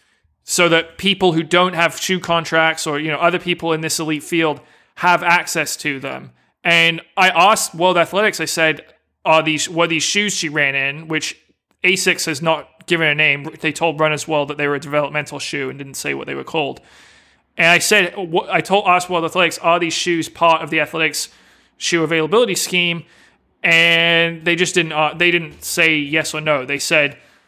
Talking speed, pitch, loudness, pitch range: 200 wpm, 165 Hz, -16 LUFS, 155-175 Hz